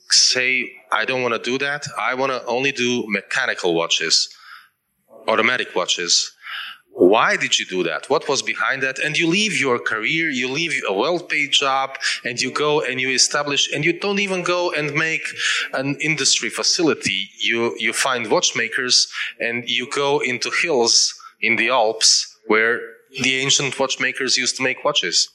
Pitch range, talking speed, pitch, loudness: 125-155 Hz, 170 wpm, 135 Hz, -18 LUFS